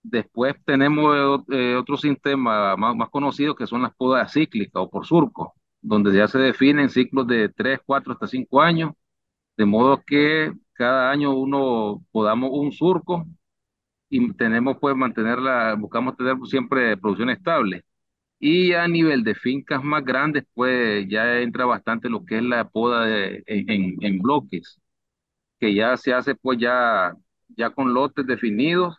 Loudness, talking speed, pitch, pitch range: -21 LUFS, 155 wpm, 130 Hz, 120-145 Hz